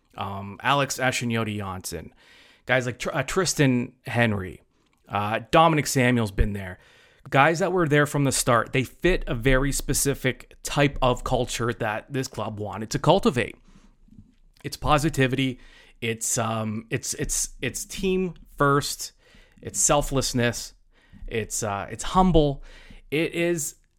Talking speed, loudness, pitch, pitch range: 135 wpm, -24 LUFS, 130 Hz, 115-145 Hz